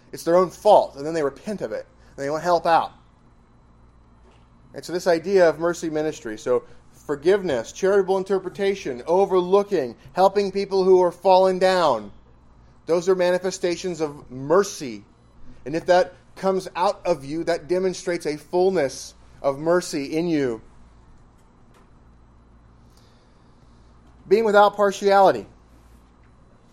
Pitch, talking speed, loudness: 165 Hz, 125 wpm, -21 LUFS